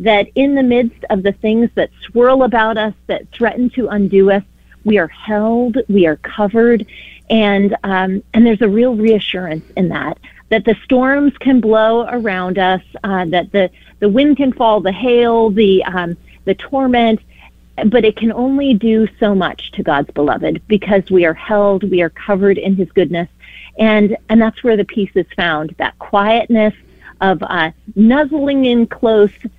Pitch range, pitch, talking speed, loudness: 190-230 Hz, 215 Hz, 175 wpm, -14 LUFS